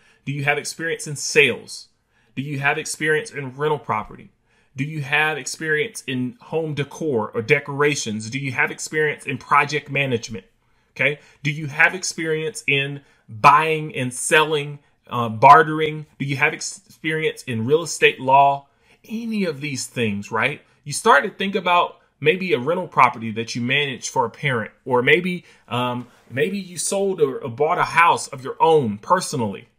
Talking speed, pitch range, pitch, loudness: 165 wpm, 130-155 Hz, 145 Hz, -20 LUFS